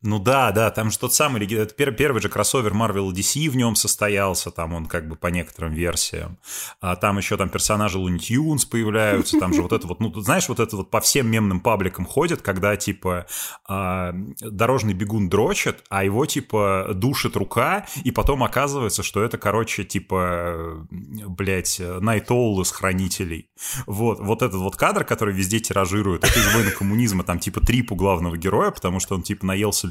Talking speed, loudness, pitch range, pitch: 180 wpm, -21 LUFS, 95-115 Hz, 105 Hz